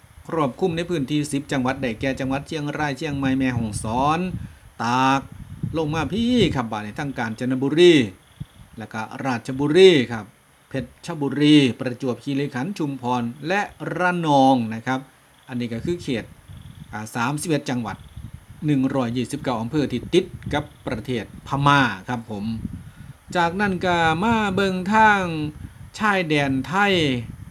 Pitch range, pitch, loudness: 125-160 Hz, 135 Hz, -22 LUFS